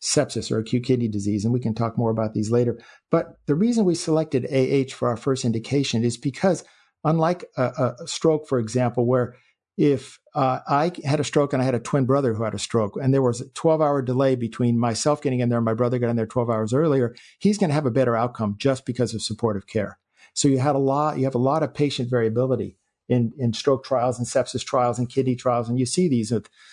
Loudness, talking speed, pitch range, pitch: -23 LUFS, 245 wpm, 120-140 Hz, 125 Hz